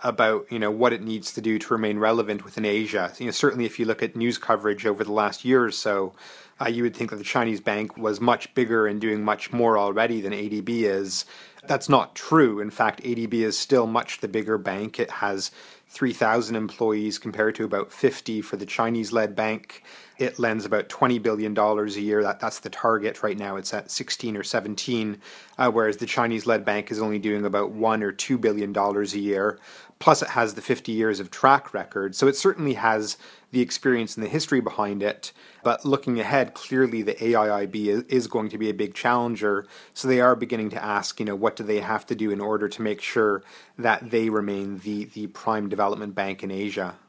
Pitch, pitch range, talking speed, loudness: 110 Hz, 105-115 Hz, 215 wpm, -24 LUFS